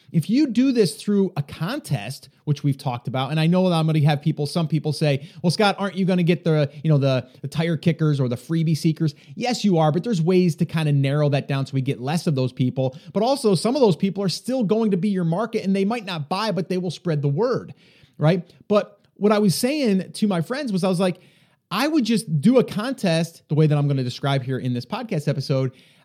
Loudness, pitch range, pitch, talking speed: -22 LUFS, 145-195 Hz, 165 Hz, 265 wpm